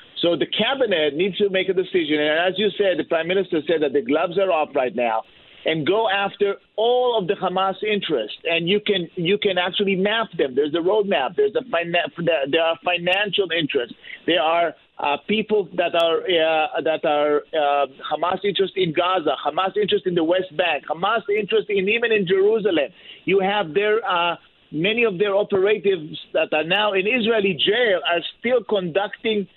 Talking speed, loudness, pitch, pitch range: 195 wpm, -21 LUFS, 190 Hz, 165-205 Hz